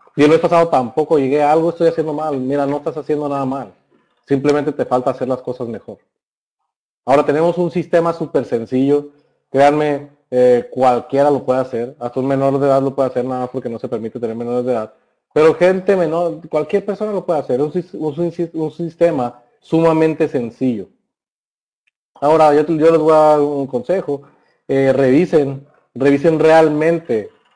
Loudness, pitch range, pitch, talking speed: -16 LUFS, 130-160 Hz, 145 Hz, 180 wpm